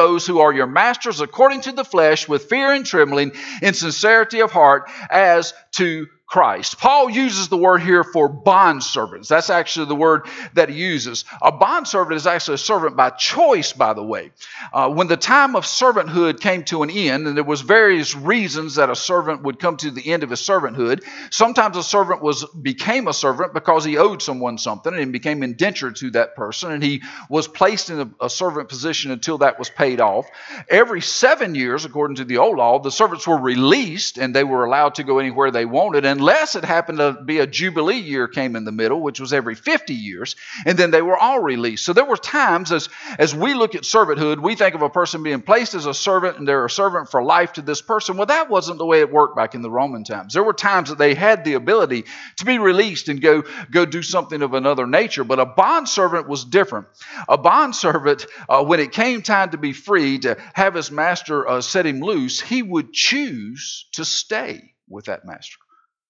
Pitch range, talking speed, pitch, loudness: 145-195 Hz, 220 wpm, 165 Hz, -17 LUFS